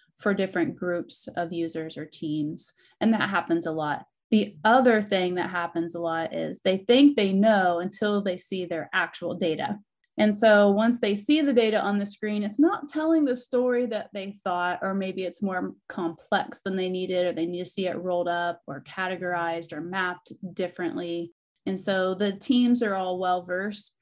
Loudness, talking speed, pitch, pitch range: -26 LUFS, 190 wpm, 190 Hz, 175-215 Hz